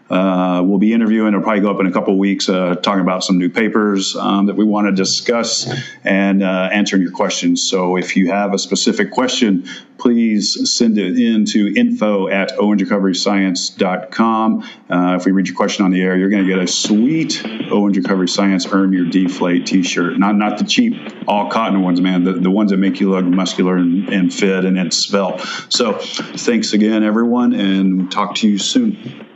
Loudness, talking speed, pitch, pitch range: -15 LUFS, 205 wpm, 100 Hz, 95-105 Hz